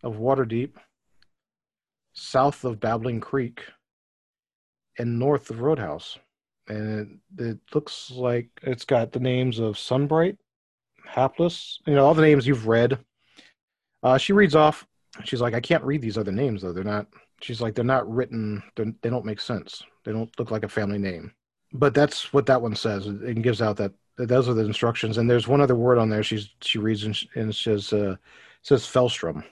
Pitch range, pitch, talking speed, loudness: 110-130 Hz, 120 Hz, 195 wpm, -24 LUFS